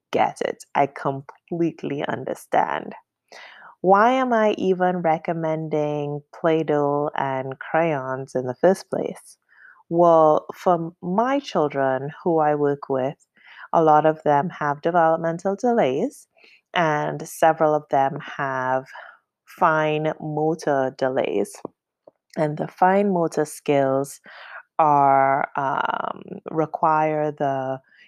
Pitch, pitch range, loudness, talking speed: 155 Hz, 140-170 Hz, -22 LUFS, 105 wpm